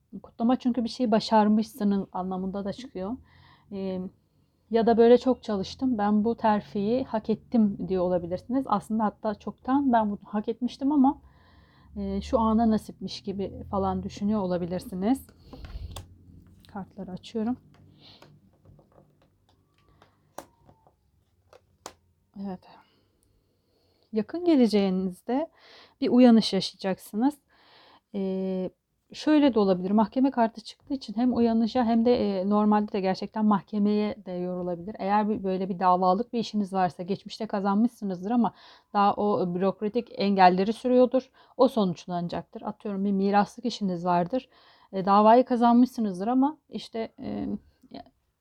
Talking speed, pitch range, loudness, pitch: 115 wpm, 190-235 Hz, -26 LUFS, 210 Hz